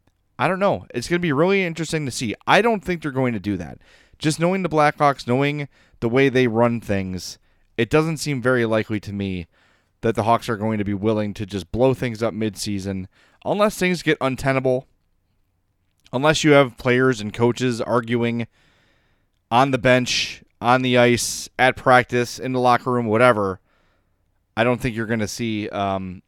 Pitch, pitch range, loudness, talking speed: 120 Hz, 105-135 Hz, -20 LUFS, 185 wpm